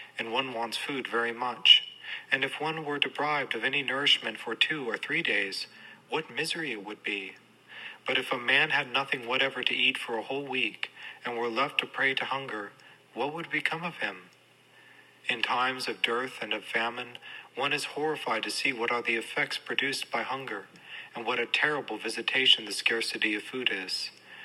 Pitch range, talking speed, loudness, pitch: 115-135 Hz, 190 wpm, -28 LUFS, 120 Hz